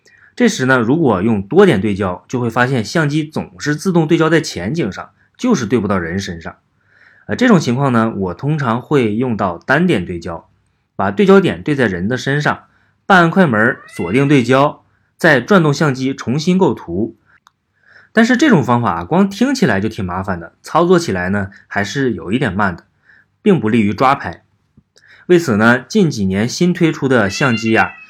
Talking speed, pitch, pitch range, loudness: 265 characters per minute, 135 Hz, 110-170 Hz, -15 LUFS